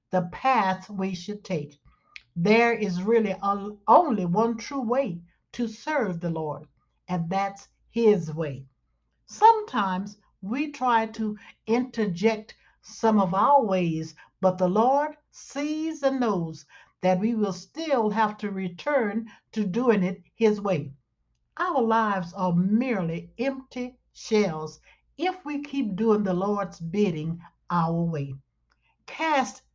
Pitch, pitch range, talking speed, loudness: 205 Hz, 180-235 Hz, 125 wpm, -26 LUFS